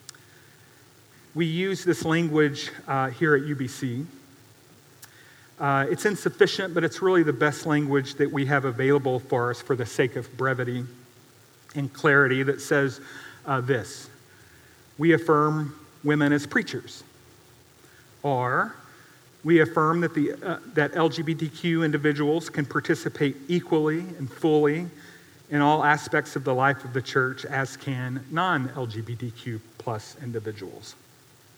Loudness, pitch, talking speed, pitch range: -25 LUFS, 140 Hz, 125 wpm, 125-155 Hz